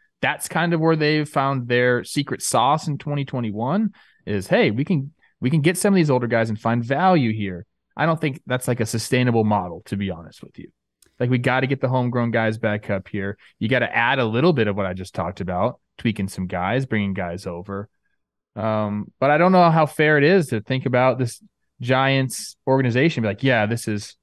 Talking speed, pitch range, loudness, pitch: 225 wpm, 105-140 Hz, -21 LUFS, 125 Hz